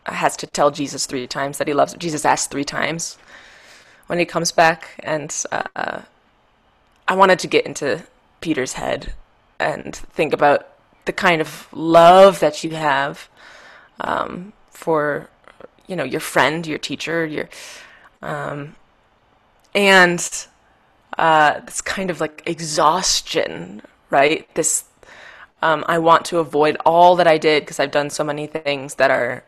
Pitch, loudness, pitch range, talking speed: 160 Hz, -18 LUFS, 150-175 Hz, 150 wpm